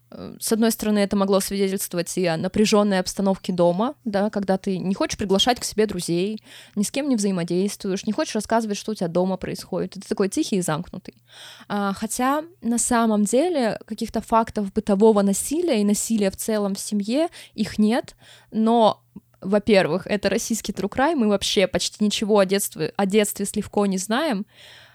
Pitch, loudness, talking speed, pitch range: 205 Hz, -22 LUFS, 170 wpm, 195-225 Hz